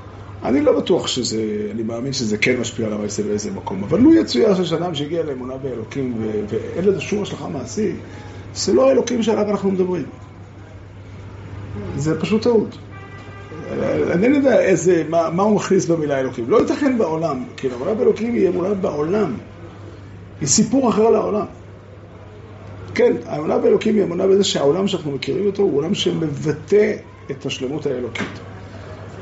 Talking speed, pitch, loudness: 150 wpm, 135 Hz, -19 LUFS